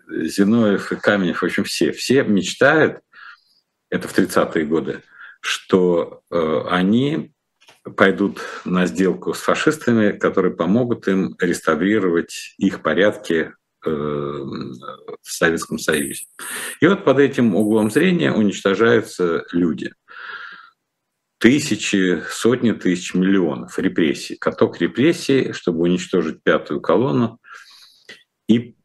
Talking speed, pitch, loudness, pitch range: 105 wpm, 100 Hz, -19 LUFS, 90-115 Hz